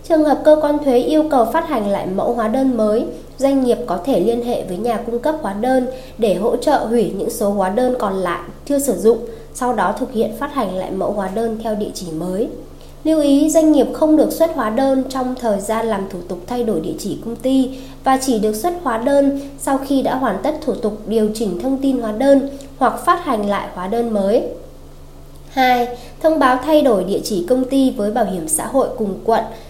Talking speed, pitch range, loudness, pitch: 235 wpm, 215-270 Hz, -17 LUFS, 240 Hz